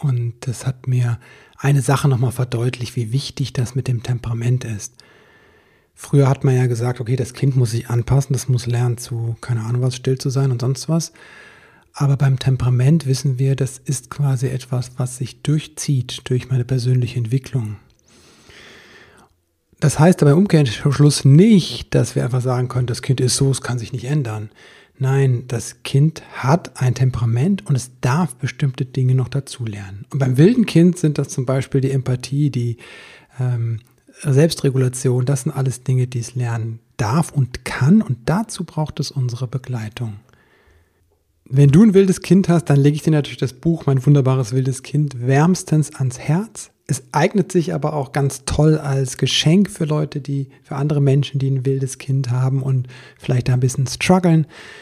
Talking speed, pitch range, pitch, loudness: 180 wpm, 125-145 Hz, 135 Hz, -18 LUFS